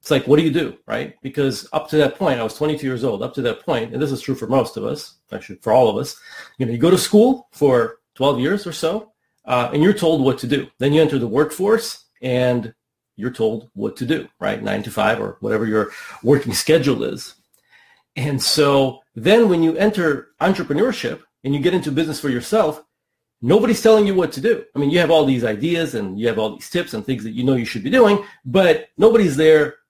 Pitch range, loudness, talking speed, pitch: 130-180 Hz, -18 LUFS, 235 wpm, 150 Hz